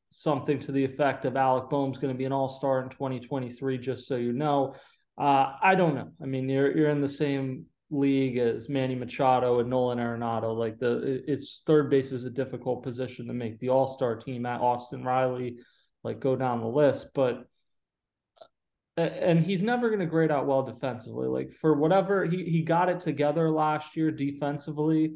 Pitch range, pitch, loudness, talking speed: 125-150 Hz, 135 Hz, -28 LUFS, 190 wpm